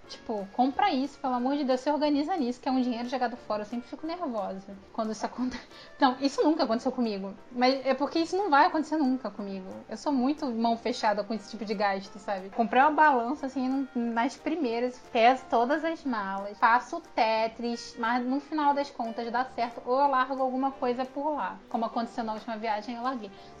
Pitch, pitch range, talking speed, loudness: 245 Hz, 230-275 Hz, 205 wpm, -28 LUFS